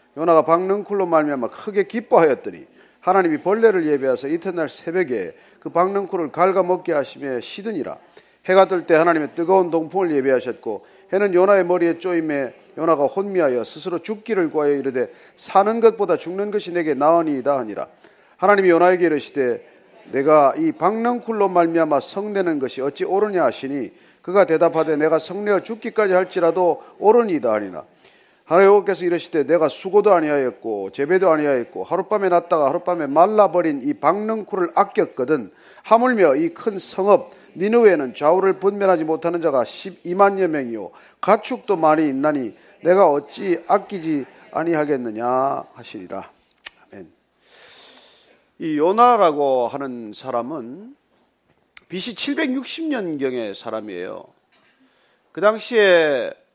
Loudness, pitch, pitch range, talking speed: -19 LUFS, 185 Hz, 160-205 Hz, 330 characters per minute